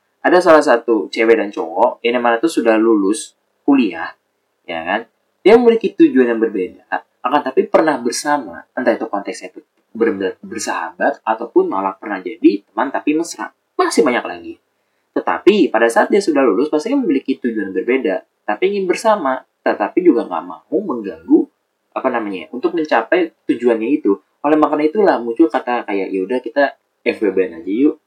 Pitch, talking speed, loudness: 220 Hz, 160 wpm, -16 LUFS